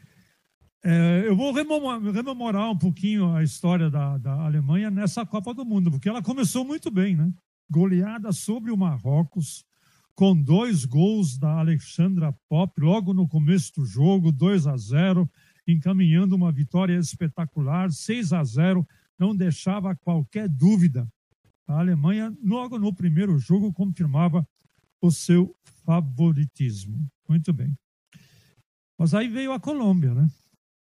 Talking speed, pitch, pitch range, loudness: 135 wpm, 175 Hz, 155-195 Hz, -23 LUFS